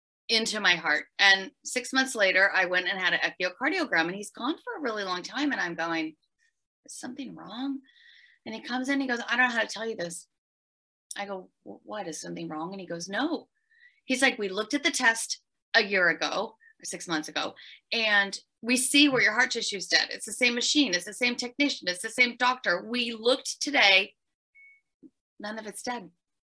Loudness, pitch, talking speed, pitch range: -26 LUFS, 225 Hz, 210 wpm, 180-270 Hz